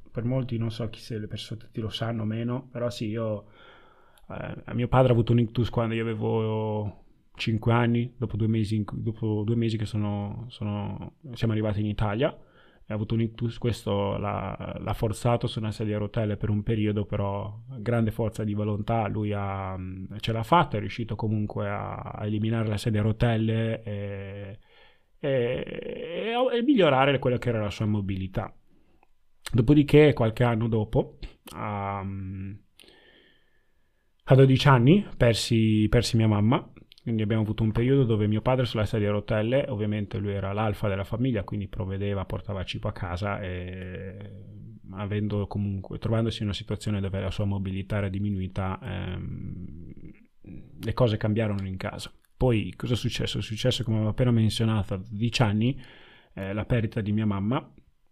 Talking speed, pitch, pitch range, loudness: 170 wpm, 110 Hz, 105-120 Hz, -27 LUFS